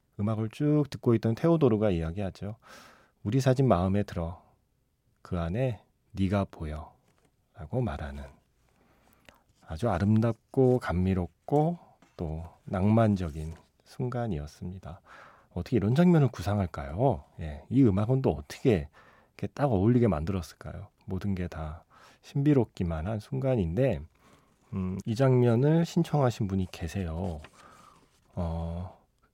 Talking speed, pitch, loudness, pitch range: 260 characters per minute, 100 Hz, -28 LUFS, 85-125 Hz